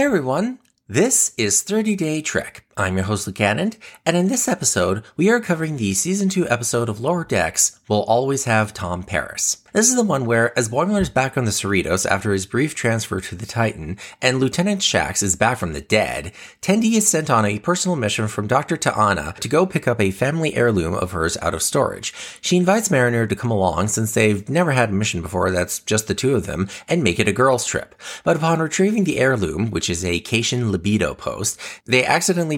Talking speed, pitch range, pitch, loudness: 215 wpm, 100-165 Hz, 120 Hz, -19 LUFS